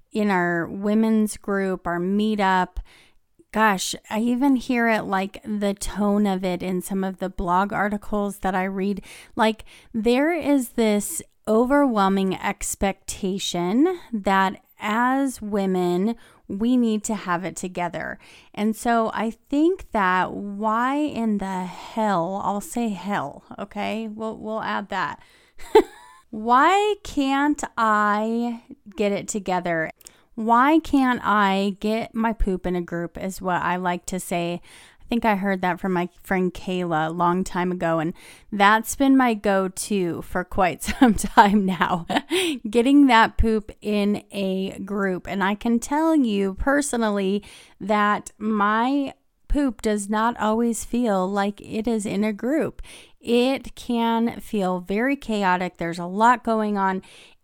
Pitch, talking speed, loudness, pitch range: 210 Hz, 145 wpm, -23 LUFS, 190-235 Hz